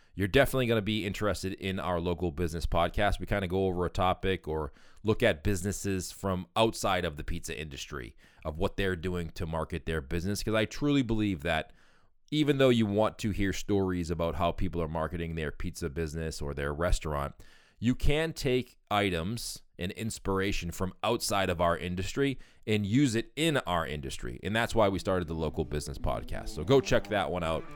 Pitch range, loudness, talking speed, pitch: 85-110 Hz, -31 LUFS, 195 wpm, 95 Hz